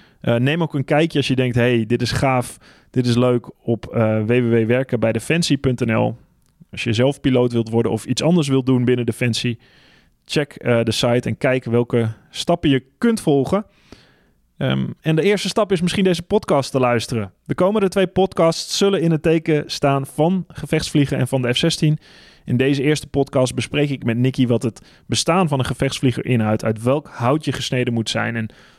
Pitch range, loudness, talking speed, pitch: 120-155 Hz, -19 LUFS, 190 wpm, 130 Hz